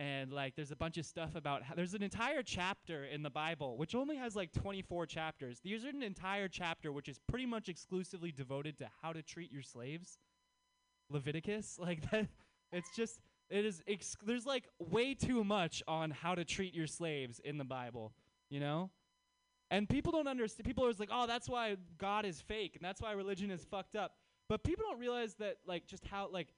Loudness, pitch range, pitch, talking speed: -41 LUFS, 155-215 Hz, 180 Hz, 210 wpm